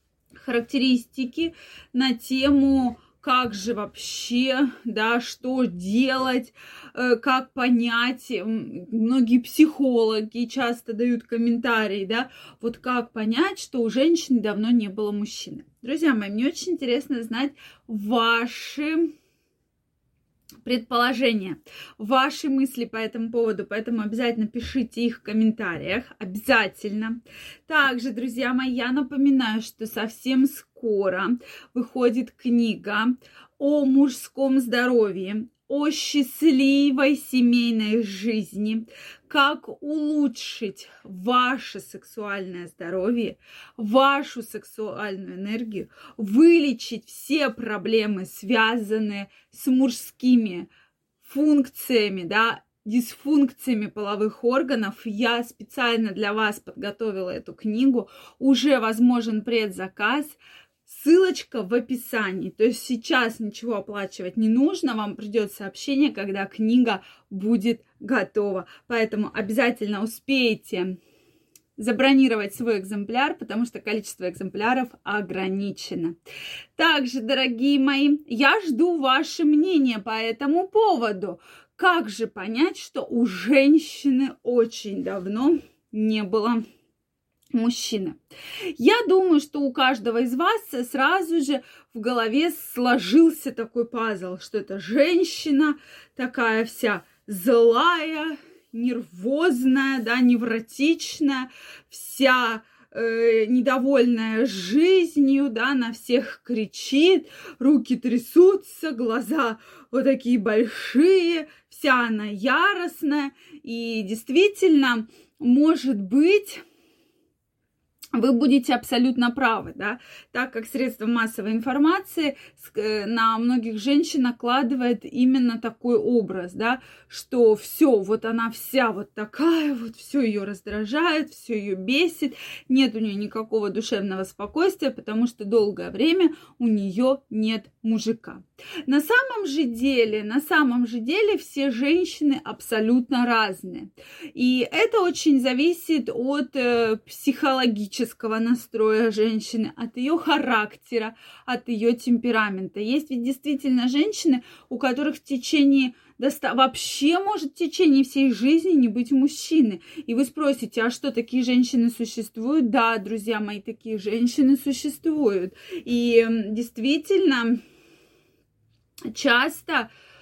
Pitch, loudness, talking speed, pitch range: 245 Hz, -23 LUFS, 105 wpm, 225-280 Hz